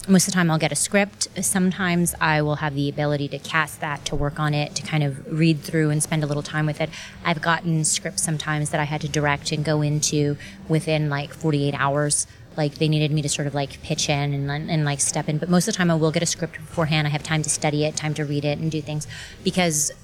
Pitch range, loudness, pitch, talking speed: 145-160 Hz, -22 LUFS, 155 Hz, 265 wpm